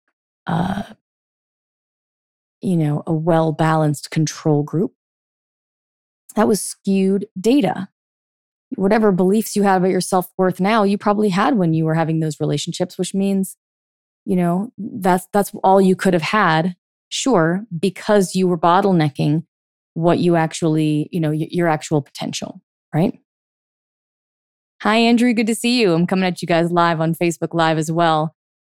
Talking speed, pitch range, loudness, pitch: 155 wpm, 160-200 Hz, -18 LUFS, 180 Hz